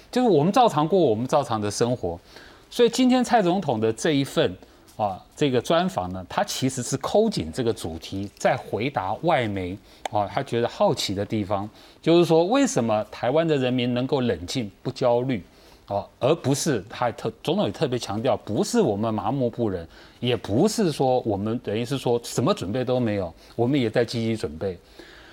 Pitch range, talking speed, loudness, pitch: 110-155 Hz, 280 characters per minute, -24 LUFS, 125 Hz